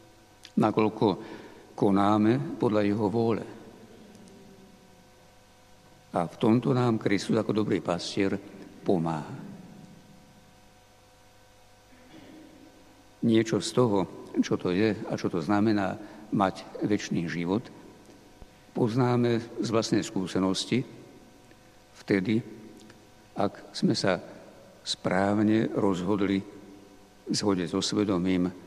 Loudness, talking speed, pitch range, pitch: -27 LUFS, 85 wpm, 100-110 Hz, 105 Hz